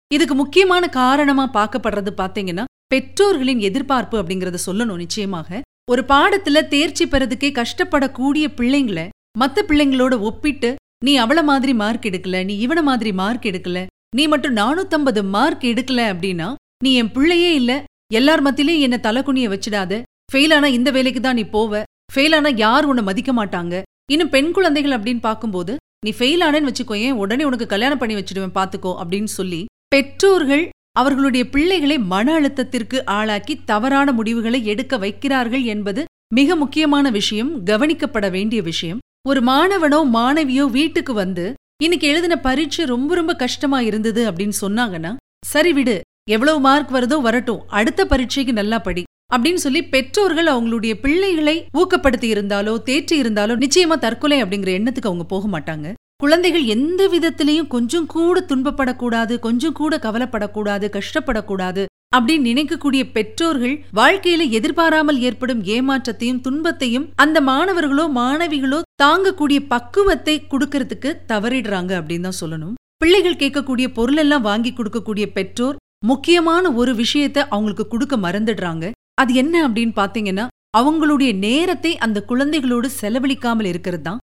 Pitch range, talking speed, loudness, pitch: 220-295 Hz, 130 wpm, -17 LUFS, 260 Hz